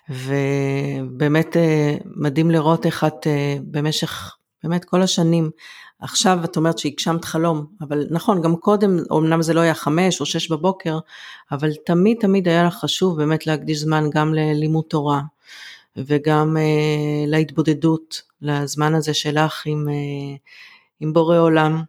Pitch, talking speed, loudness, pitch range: 155 Hz, 130 wpm, -19 LUFS, 150-165 Hz